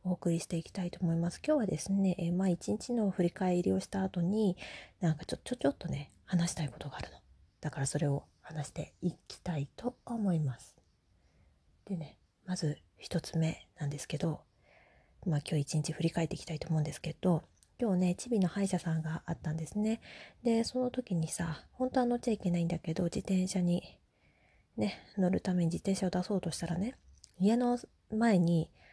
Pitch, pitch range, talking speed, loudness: 175 Hz, 155-195 Hz, 370 characters per minute, -34 LUFS